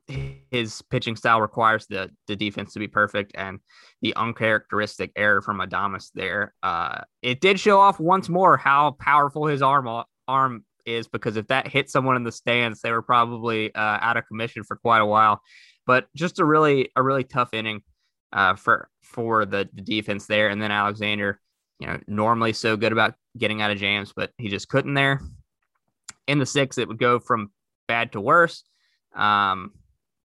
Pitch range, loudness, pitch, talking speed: 105-135 Hz, -22 LUFS, 115 Hz, 185 wpm